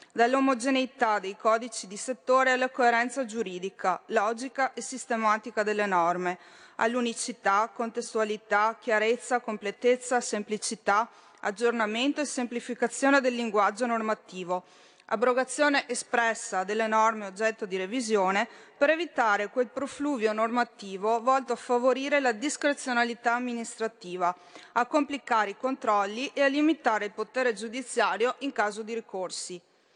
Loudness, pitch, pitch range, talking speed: -28 LUFS, 235 Hz, 210-255 Hz, 110 wpm